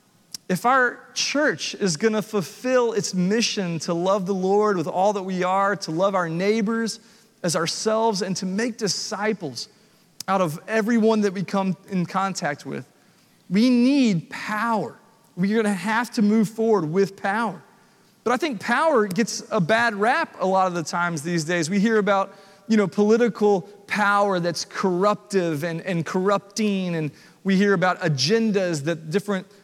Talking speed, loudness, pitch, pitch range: 170 wpm, -22 LUFS, 200 Hz, 180-220 Hz